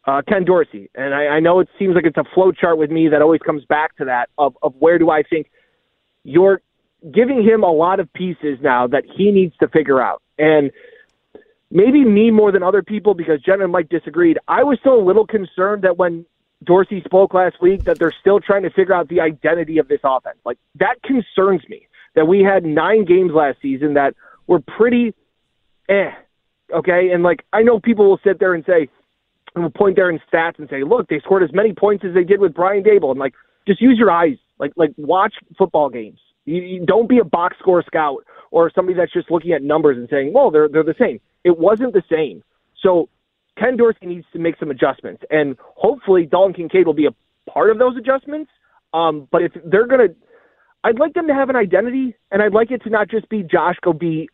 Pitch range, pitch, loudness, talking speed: 160-215 Hz, 180 Hz, -16 LUFS, 225 wpm